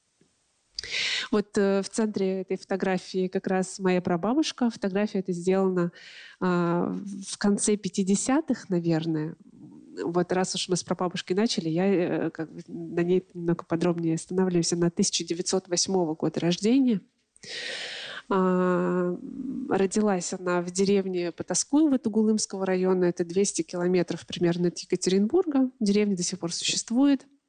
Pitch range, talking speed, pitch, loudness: 175-210 Hz, 110 wpm, 185 Hz, -26 LUFS